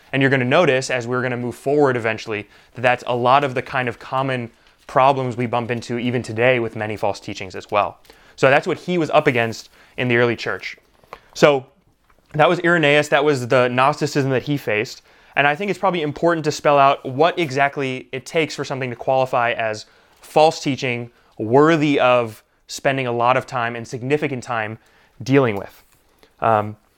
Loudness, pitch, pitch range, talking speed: -19 LUFS, 130 Hz, 120-145 Hz, 195 wpm